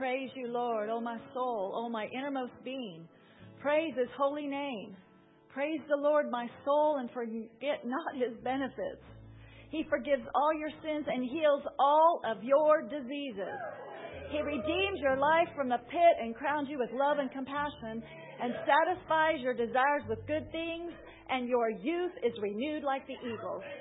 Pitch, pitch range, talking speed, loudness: 270 Hz, 240-300 Hz, 165 wpm, -32 LUFS